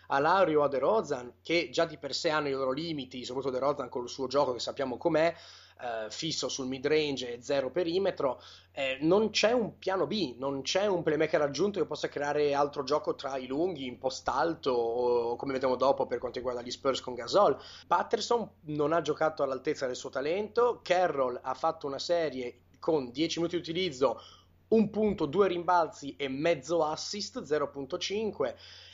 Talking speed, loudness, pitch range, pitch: 185 wpm, -30 LUFS, 135-175 Hz, 150 Hz